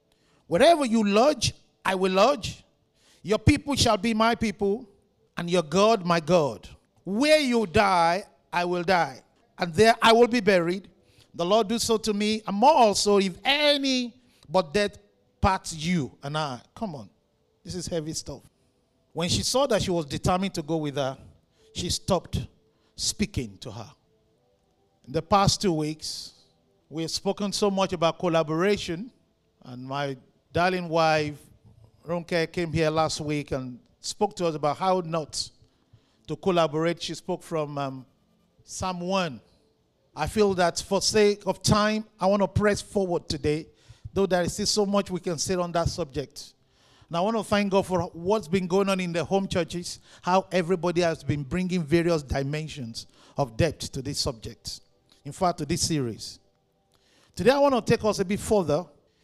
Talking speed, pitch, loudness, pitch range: 170 wpm, 175 Hz, -25 LUFS, 150-200 Hz